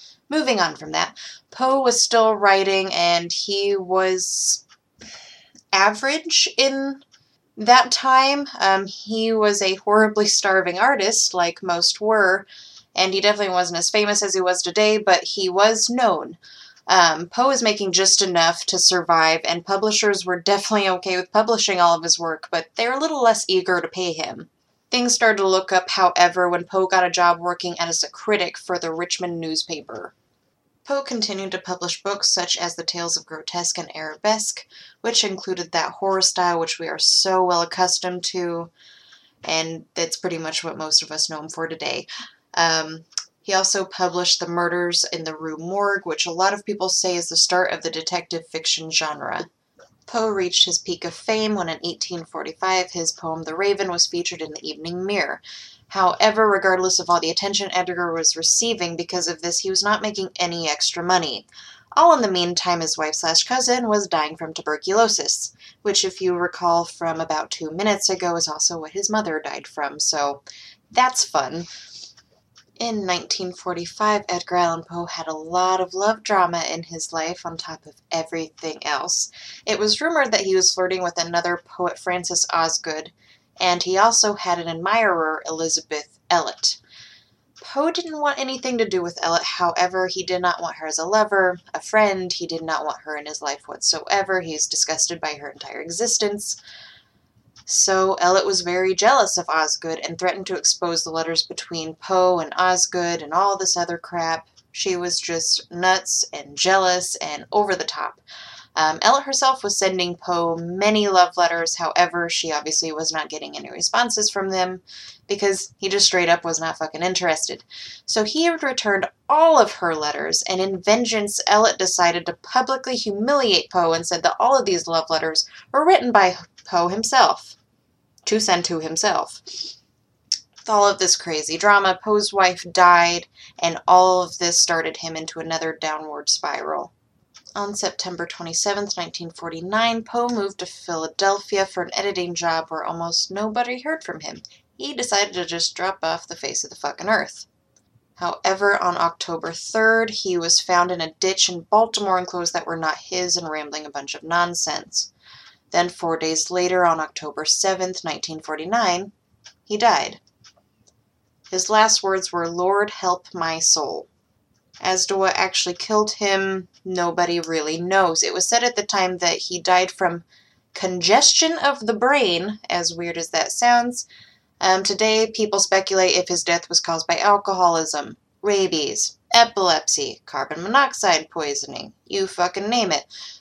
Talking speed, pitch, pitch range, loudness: 170 wpm, 180 Hz, 165-200 Hz, -20 LUFS